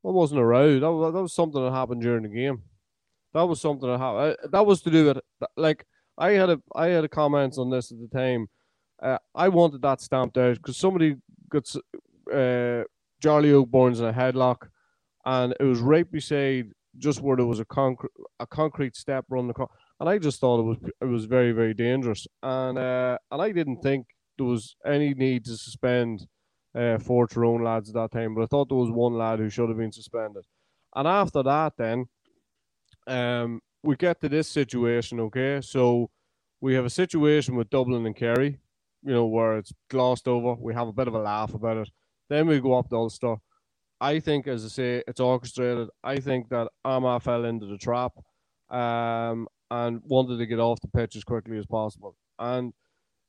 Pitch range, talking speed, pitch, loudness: 115-140 Hz, 205 wpm, 125 Hz, -25 LUFS